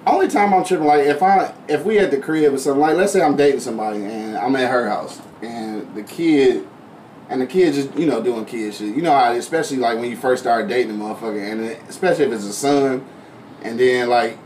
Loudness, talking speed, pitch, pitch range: -18 LUFS, 245 wpm, 135 Hz, 115-185 Hz